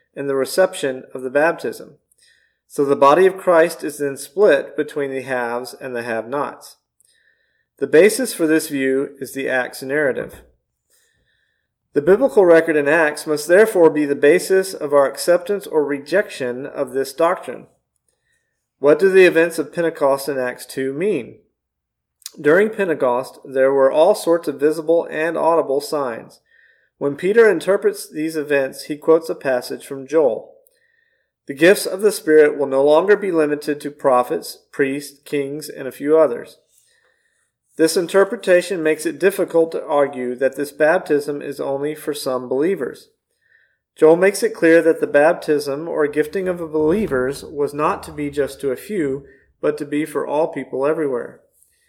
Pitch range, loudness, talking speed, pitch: 140-180 Hz, -18 LUFS, 160 wpm, 150 Hz